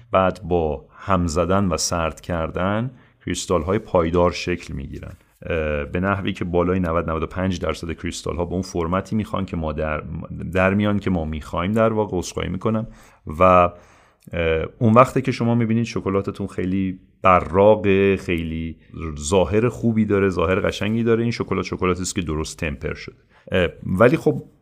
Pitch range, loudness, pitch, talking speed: 85-105 Hz, -21 LUFS, 95 Hz, 155 wpm